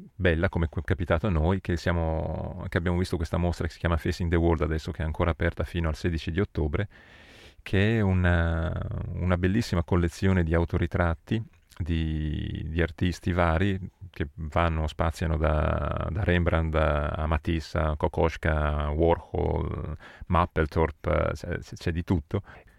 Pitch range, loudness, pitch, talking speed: 80-95 Hz, -27 LUFS, 85 Hz, 145 wpm